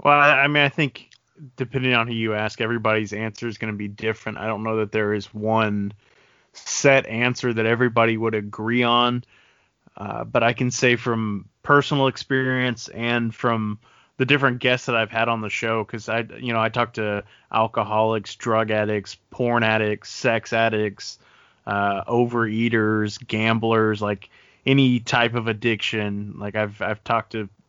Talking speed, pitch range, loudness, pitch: 165 wpm, 110-120 Hz, -22 LUFS, 115 Hz